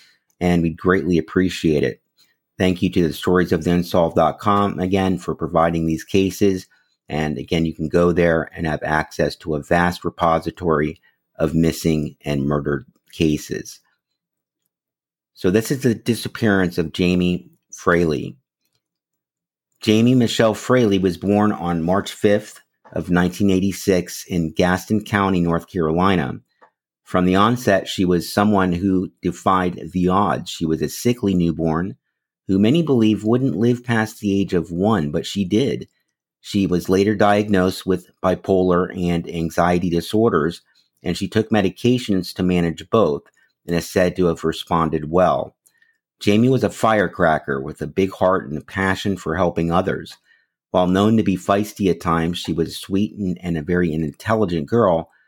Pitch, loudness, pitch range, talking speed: 90 Hz, -19 LUFS, 85-100 Hz, 150 wpm